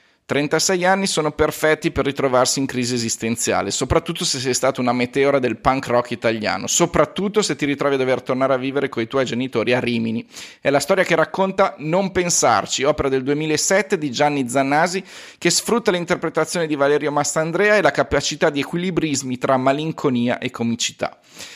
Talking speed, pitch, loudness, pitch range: 175 wpm, 145 Hz, -19 LUFS, 130-170 Hz